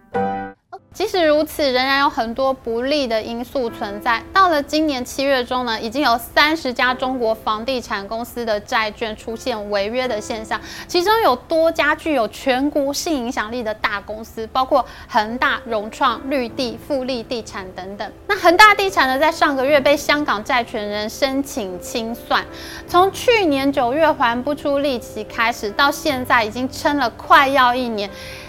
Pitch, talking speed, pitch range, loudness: 260 Hz, 255 characters per minute, 230-295 Hz, -18 LUFS